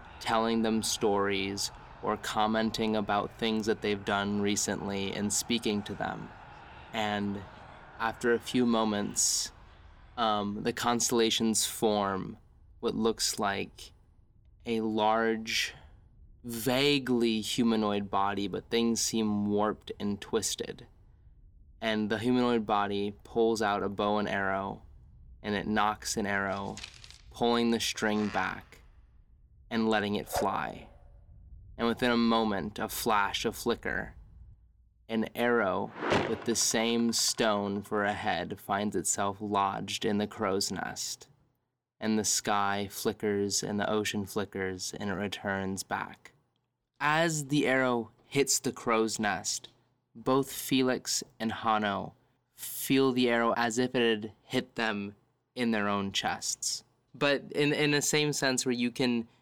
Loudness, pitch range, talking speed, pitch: -30 LUFS, 100-120 Hz, 130 wpm, 110 Hz